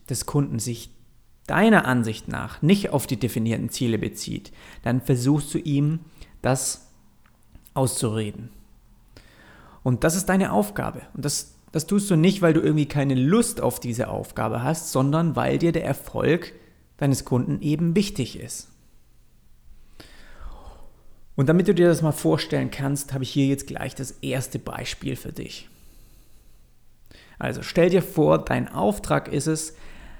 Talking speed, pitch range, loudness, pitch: 145 wpm, 120-160 Hz, -23 LUFS, 135 Hz